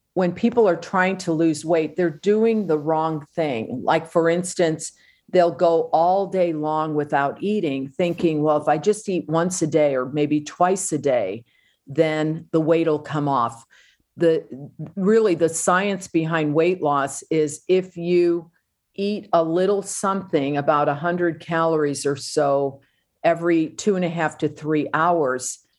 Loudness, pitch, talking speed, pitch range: -21 LUFS, 165 Hz, 165 wpm, 150-175 Hz